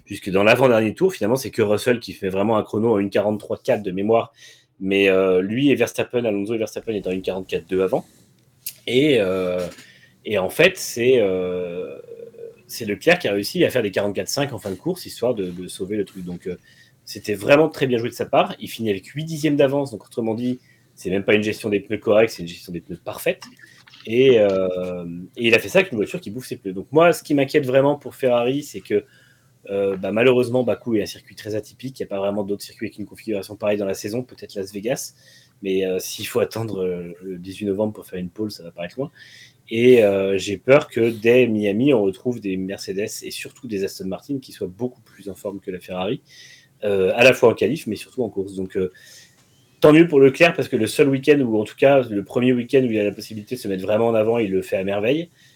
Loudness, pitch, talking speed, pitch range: -20 LUFS, 105 Hz, 240 wpm, 95-125 Hz